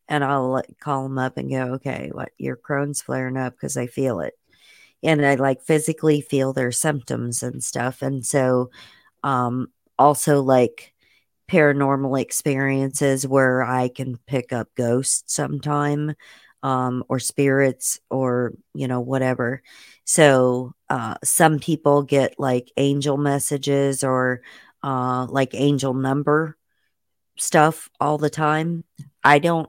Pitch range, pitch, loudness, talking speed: 130-145 Hz, 135 Hz, -21 LUFS, 135 wpm